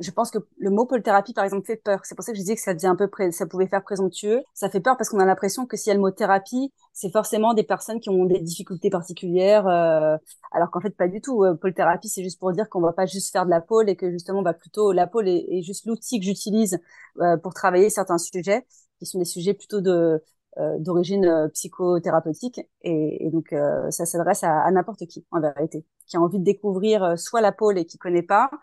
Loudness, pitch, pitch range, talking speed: -23 LUFS, 190 Hz, 175-210 Hz, 250 wpm